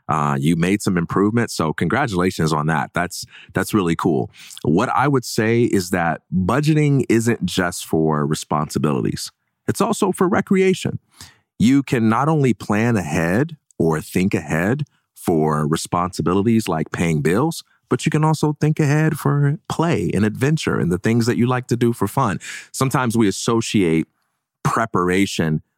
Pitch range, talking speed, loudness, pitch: 90-145 Hz, 155 wpm, -19 LUFS, 115 Hz